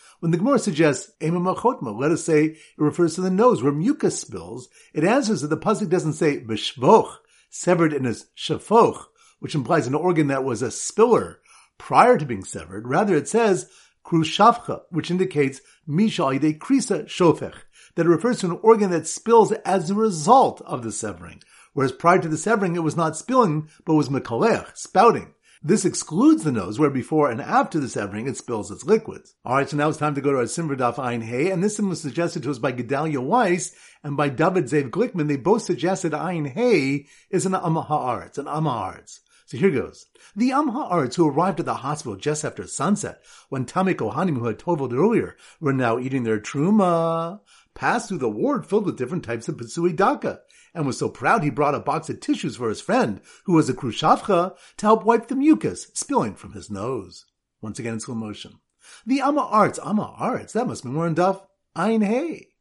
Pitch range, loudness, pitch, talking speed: 145-205 Hz, -22 LUFS, 170 Hz, 195 wpm